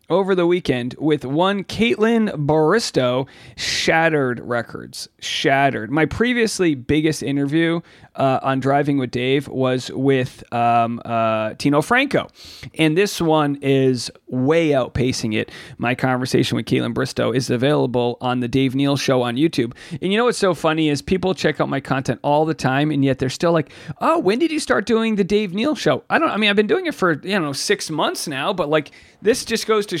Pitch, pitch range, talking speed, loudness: 150 Hz, 130-185 Hz, 190 wpm, -19 LUFS